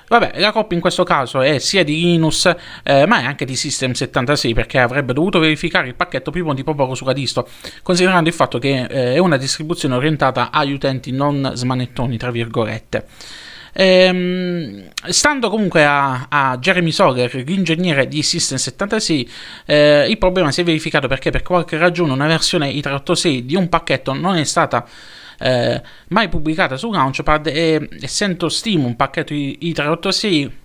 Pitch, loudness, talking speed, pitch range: 155 Hz, -16 LUFS, 160 wpm, 135-175 Hz